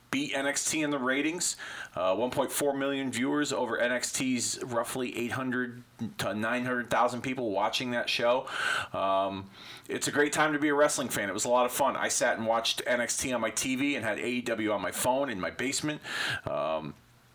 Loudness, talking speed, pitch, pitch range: -29 LUFS, 185 wpm, 130 Hz, 120-145 Hz